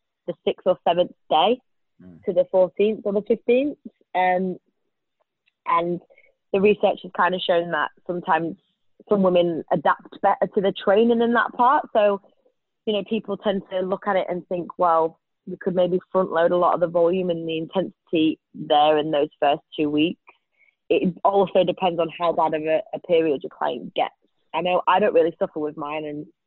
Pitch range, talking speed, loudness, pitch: 165-200 Hz, 190 wpm, -22 LUFS, 180 Hz